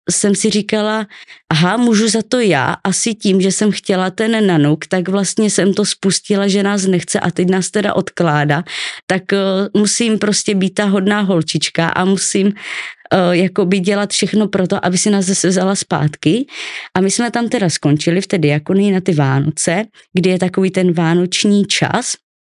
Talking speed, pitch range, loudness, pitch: 180 wpm, 180-210 Hz, -15 LUFS, 195 Hz